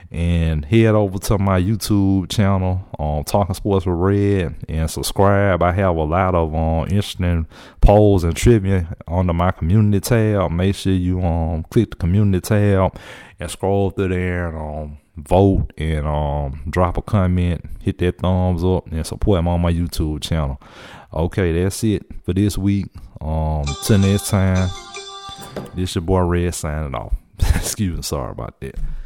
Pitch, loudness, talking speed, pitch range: 90 Hz, -19 LUFS, 170 wpm, 80-100 Hz